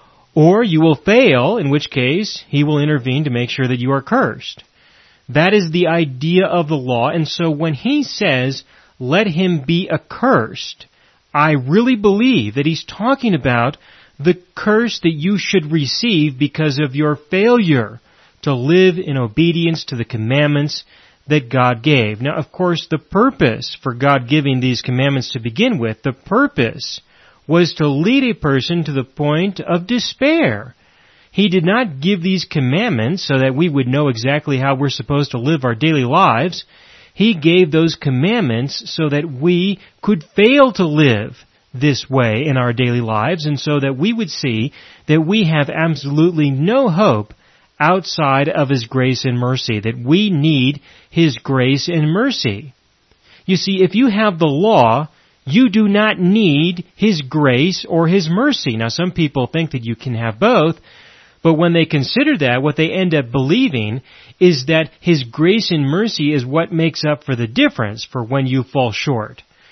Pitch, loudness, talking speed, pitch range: 150 Hz, -15 LUFS, 170 wpm, 135-180 Hz